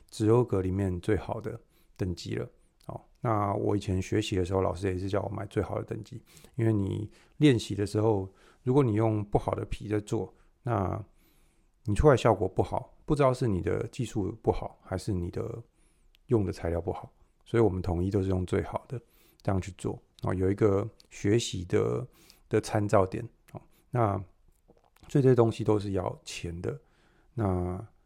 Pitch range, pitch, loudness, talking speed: 95-115 Hz, 105 Hz, -29 LUFS, 255 characters per minute